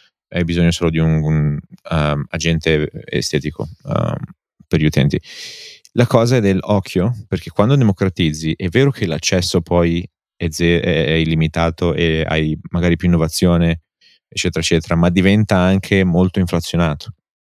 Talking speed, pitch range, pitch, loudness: 135 wpm, 80-95 Hz, 85 Hz, -17 LUFS